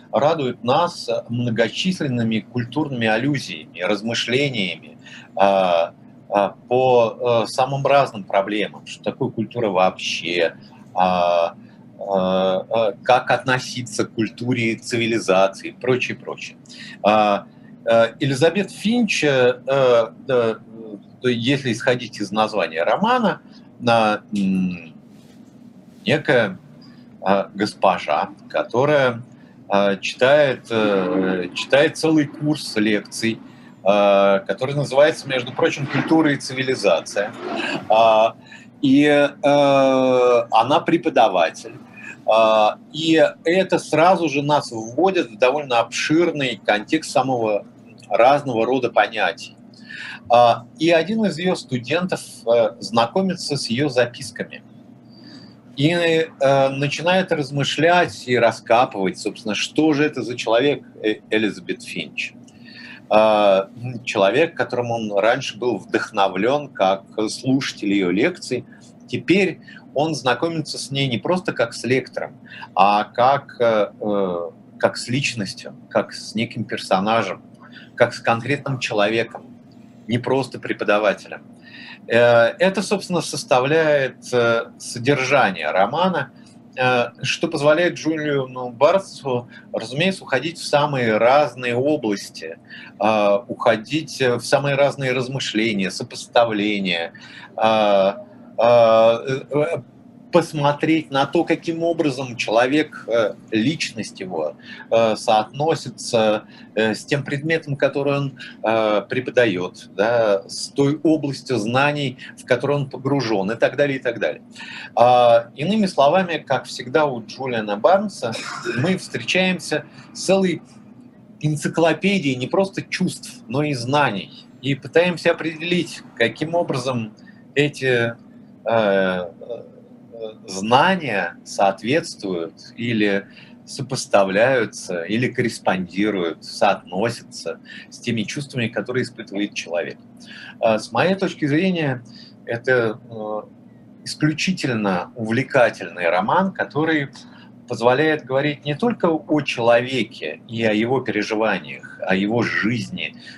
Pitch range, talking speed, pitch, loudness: 110-150 Hz, 90 wpm, 125 Hz, -20 LUFS